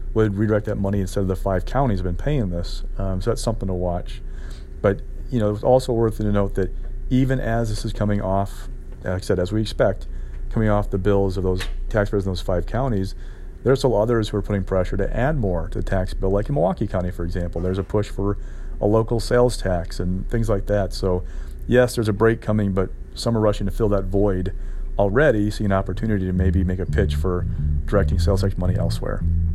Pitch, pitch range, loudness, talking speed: 100 Hz, 90-110 Hz, -22 LUFS, 230 wpm